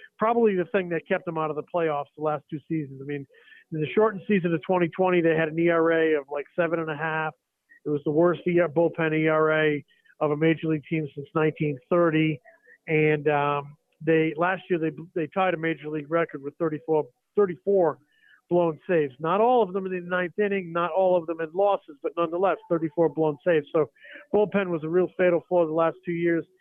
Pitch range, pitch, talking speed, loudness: 155-180 Hz, 165 Hz, 210 wpm, -25 LUFS